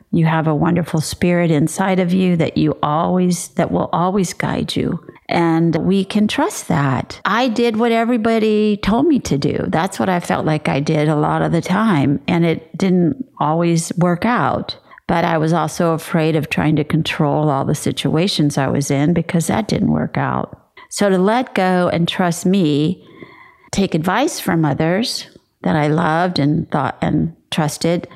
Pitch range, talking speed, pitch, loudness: 155-195 Hz, 180 wpm, 170 Hz, -17 LUFS